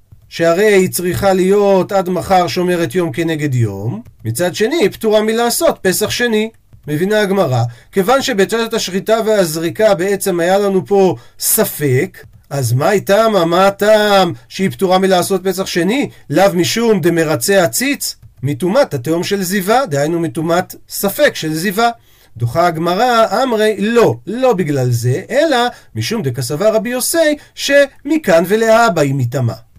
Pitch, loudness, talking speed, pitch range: 190 Hz, -14 LUFS, 135 wpm, 150-215 Hz